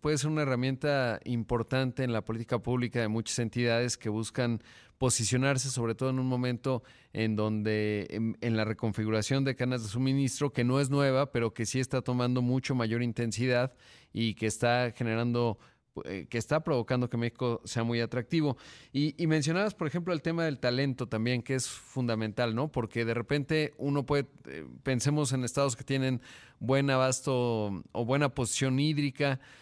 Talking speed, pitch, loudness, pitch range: 175 wpm, 125 Hz, -30 LUFS, 115-135 Hz